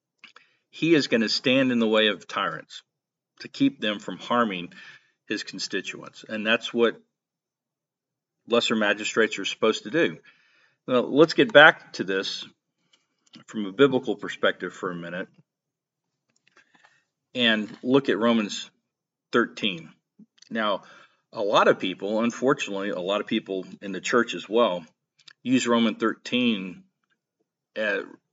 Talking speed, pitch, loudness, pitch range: 135 wpm, 115 Hz, -24 LUFS, 105-140 Hz